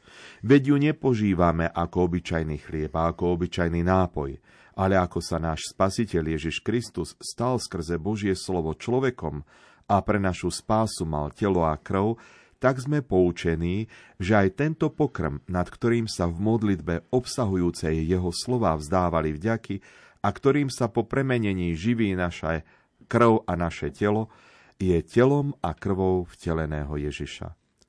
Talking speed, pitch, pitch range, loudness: 140 wpm, 95 Hz, 85-115 Hz, -26 LUFS